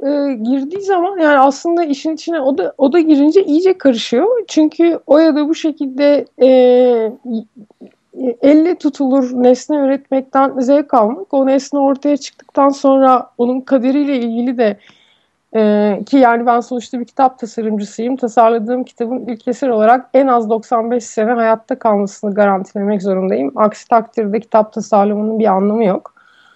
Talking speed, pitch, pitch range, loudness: 140 wpm, 255 Hz, 230-285 Hz, -14 LUFS